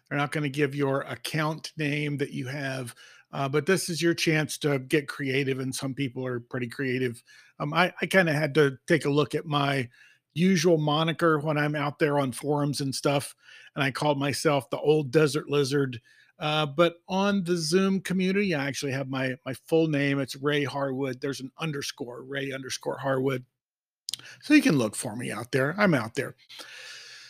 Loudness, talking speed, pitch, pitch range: -27 LUFS, 195 wpm, 145 Hz, 135-160 Hz